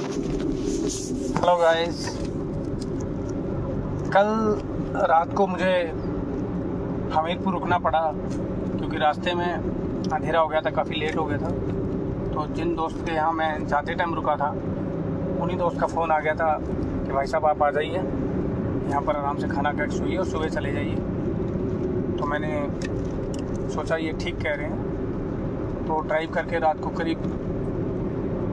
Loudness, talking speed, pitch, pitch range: -25 LUFS, 145 wpm, 160 Hz, 150-175 Hz